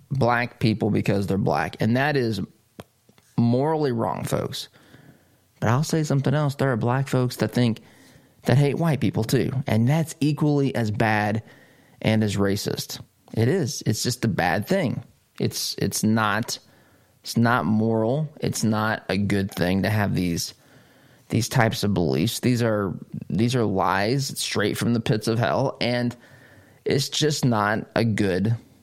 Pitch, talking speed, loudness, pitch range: 115 Hz, 160 wpm, -23 LUFS, 110-135 Hz